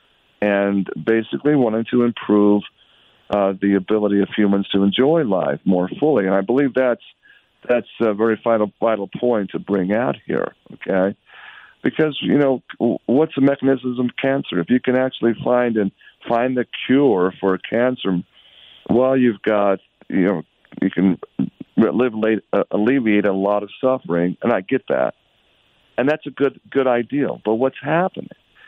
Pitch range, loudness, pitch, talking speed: 100-130 Hz, -19 LUFS, 115 Hz, 155 wpm